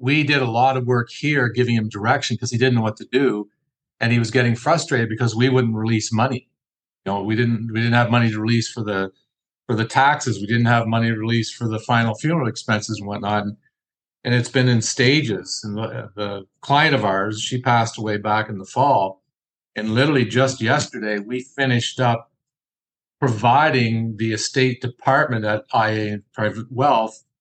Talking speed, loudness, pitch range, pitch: 195 wpm, -20 LUFS, 110-130 Hz, 115 Hz